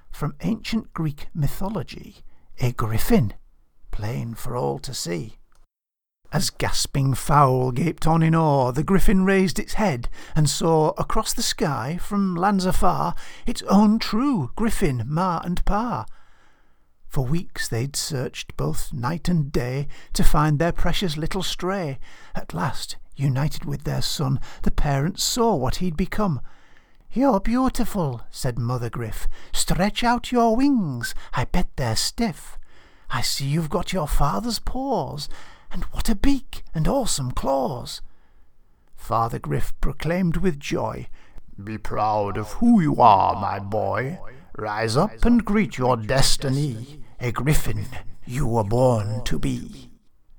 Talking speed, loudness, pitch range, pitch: 140 wpm, -23 LUFS, 125-190 Hz, 150 Hz